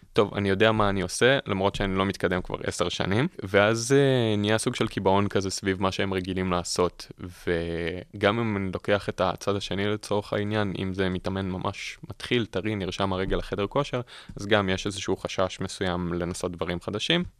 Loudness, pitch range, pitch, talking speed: -26 LUFS, 95-105 Hz, 100 Hz, 185 wpm